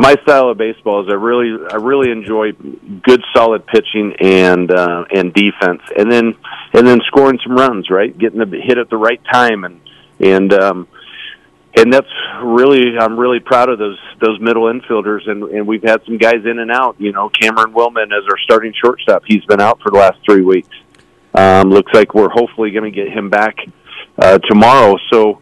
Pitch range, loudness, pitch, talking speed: 100-120 Hz, -11 LUFS, 110 Hz, 200 wpm